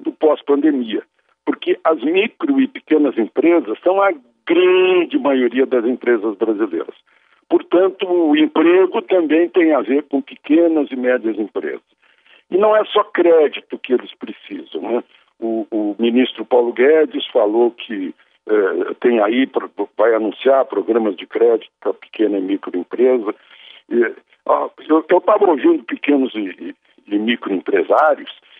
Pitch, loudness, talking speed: 200 Hz, -16 LUFS, 130 wpm